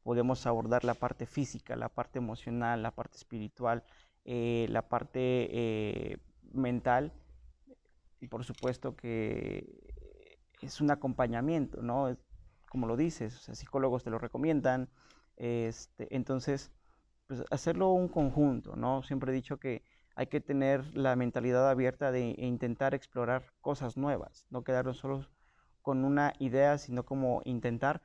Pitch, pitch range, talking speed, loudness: 125 Hz, 120-135 Hz, 140 wpm, -34 LUFS